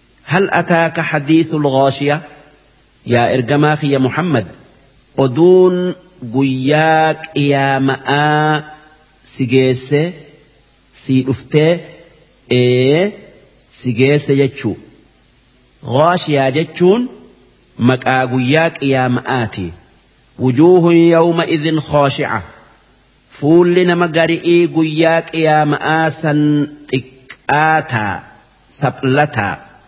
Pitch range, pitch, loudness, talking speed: 130-160 Hz, 150 Hz, -14 LUFS, 65 wpm